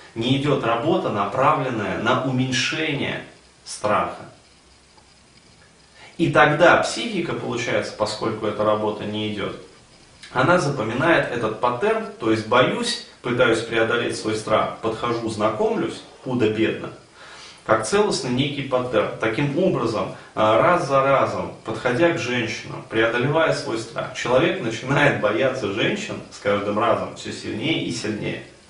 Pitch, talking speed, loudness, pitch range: 125 Hz, 115 wpm, -21 LUFS, 110-150 Hz